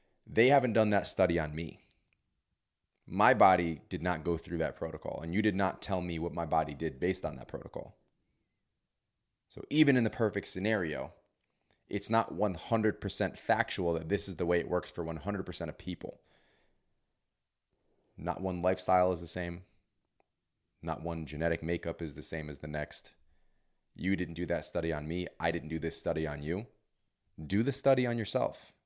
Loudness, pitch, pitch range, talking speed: -32 LUFS, 90 Hz, 85-100 Hz, 175 wpm